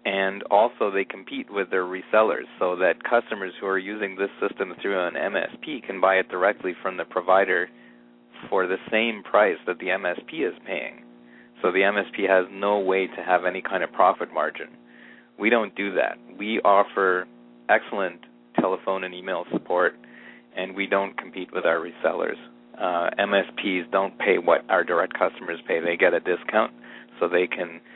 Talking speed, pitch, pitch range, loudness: 175 wpm, 90 Hz, 60-95 Hz, -24 LUFS